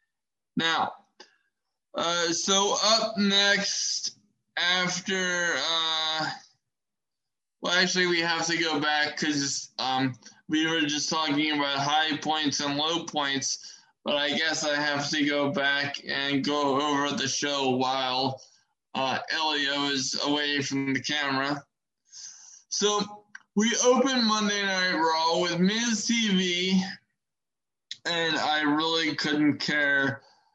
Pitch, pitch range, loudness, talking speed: 155 Hz, 140-180 Hz, -25 LUFS, 120 wpm